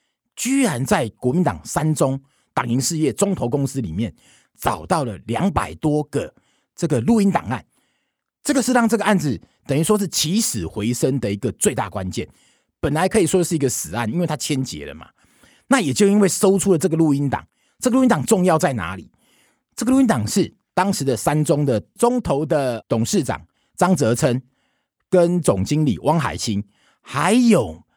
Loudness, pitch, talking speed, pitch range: -20 LUFS, 160 Hz, 265 characters per minute, 130-200 Hz